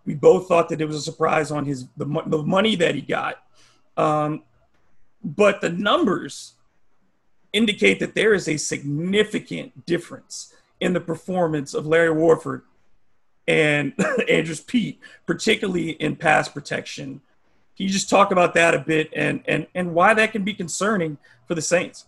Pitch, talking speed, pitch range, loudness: 165 Hz, 165 wpm, 155-190 Hz, -21 LUFS